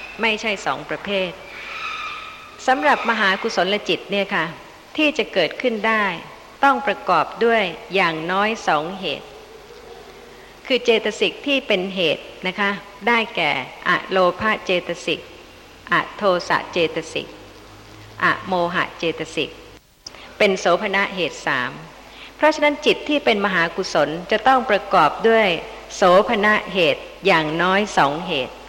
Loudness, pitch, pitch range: -19 LUFS, 205 Hz, 180-250 Hz